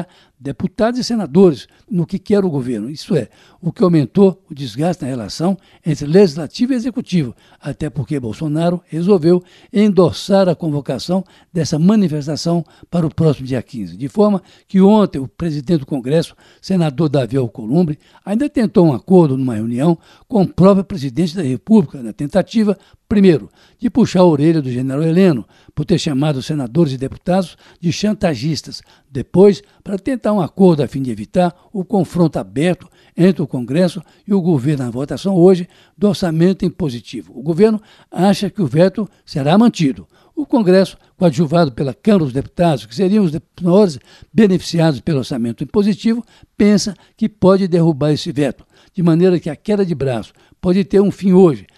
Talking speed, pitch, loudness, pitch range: 165 wpm, 175 Hz, -16 LUFS, 150-195 Hz